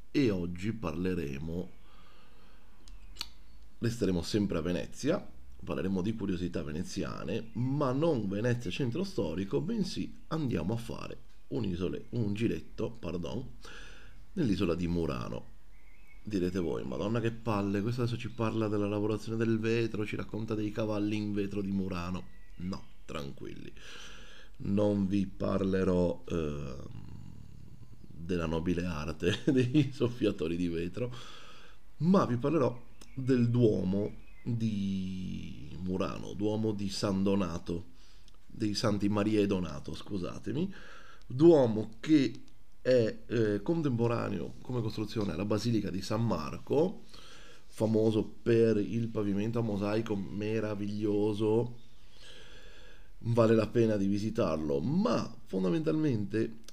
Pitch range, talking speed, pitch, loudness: 90-115 Hz, 110 wpm, 105 Hz, -32 LUFS